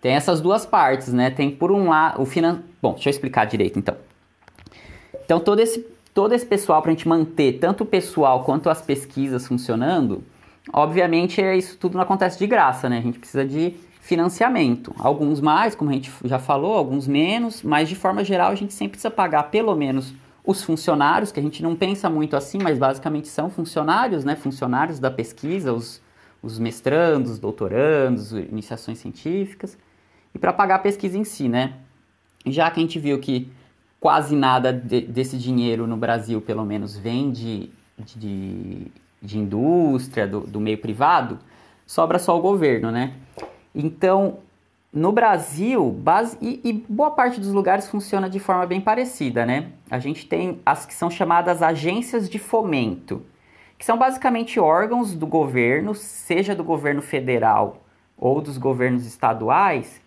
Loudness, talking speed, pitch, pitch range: -21 LUFS, 170 wpm, 155 Hz, 125-190 Hz